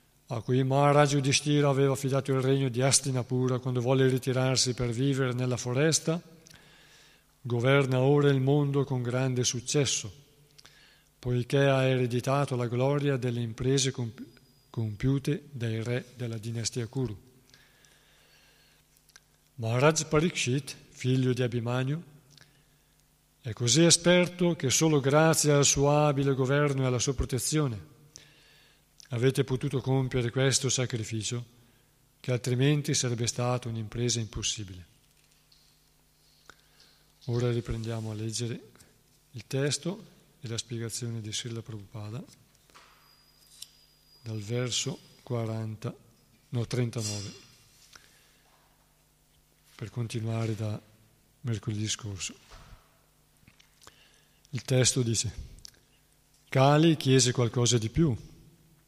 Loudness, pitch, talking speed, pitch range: -28 LUFS, 130 Hz, 100 wpm, 120-140 Hz